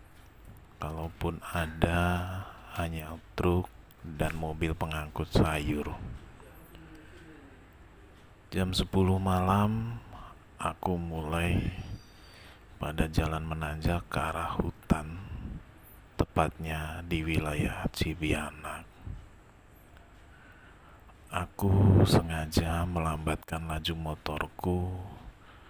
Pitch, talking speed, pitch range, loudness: 85 Hz, 65 wpm, 80-95 Hz, -31 LUFS